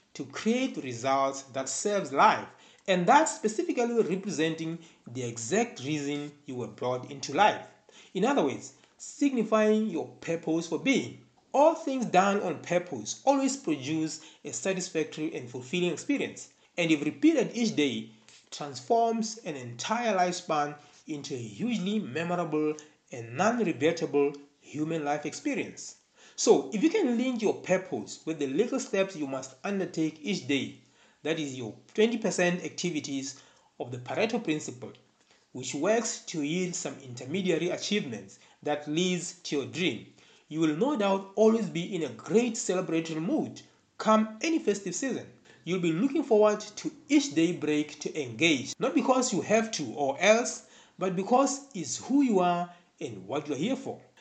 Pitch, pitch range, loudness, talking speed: 175 Hz, 150-220 Hz, -29 LUFS, 150 wpm